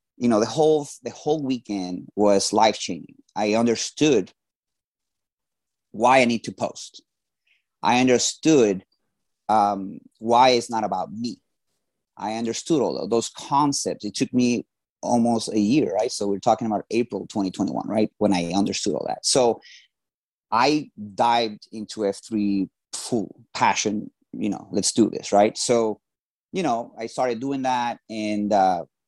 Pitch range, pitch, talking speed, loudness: 105-125 Hz, 110 Hz, 150 wpm, -23 LUFS